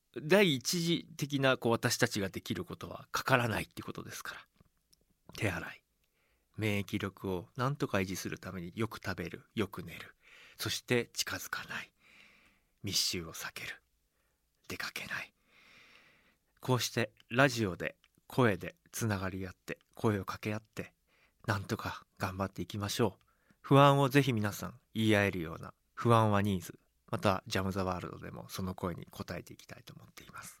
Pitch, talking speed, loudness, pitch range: 105 Hz, 320 characters per minute, -33 LUFS, 95-125 Hz